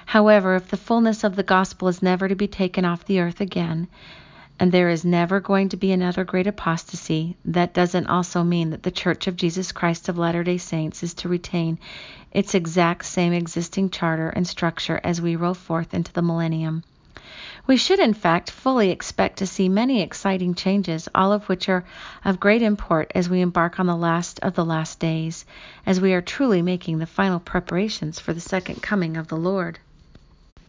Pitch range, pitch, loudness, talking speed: 170-195 Hz, 180 Hz, -22 LUFS, 195 wpm